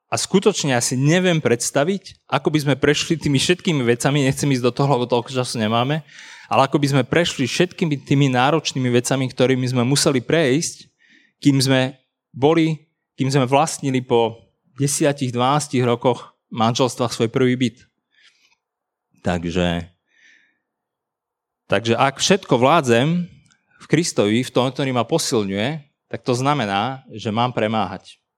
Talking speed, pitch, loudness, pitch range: 135 wpm, 135 Hz, -19 LUFS, 120-150 Hz